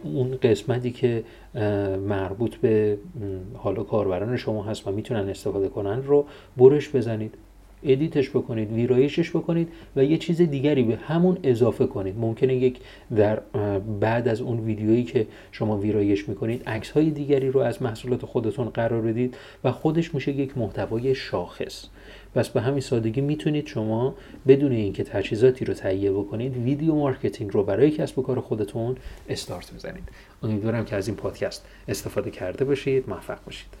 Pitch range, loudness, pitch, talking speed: 105-135 Hz, -24 LUFS, 120 Hz, 155 wpm